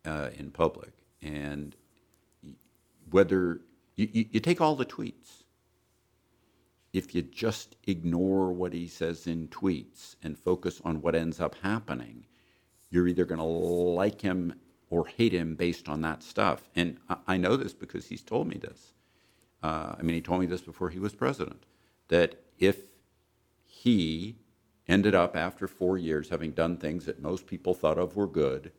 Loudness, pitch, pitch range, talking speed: -30 LUFS, 90 Hz, 80-95 Hz, 165 wpm